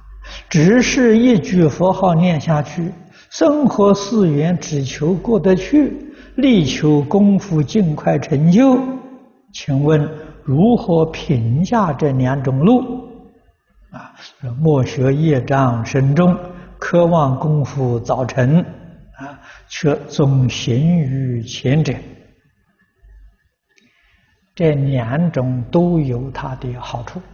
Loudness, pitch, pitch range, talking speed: -16 LUFS, 160 Hz, 135-195 Hz, 145 characters per minute